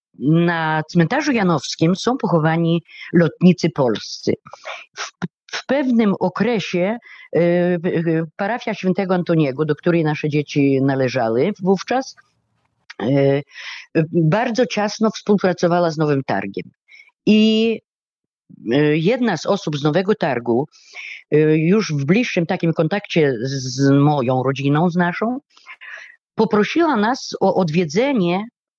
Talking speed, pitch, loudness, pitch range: 100 wpm, 180 Hz, -18 LUFS, 155-215 Hz